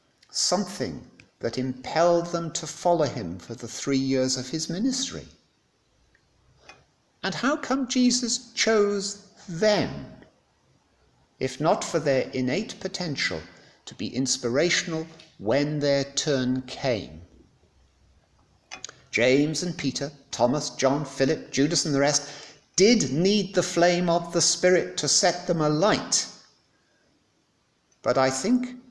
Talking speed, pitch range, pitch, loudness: 120 wpm, 130-185 Hz, 155 Hz, -25 LUFS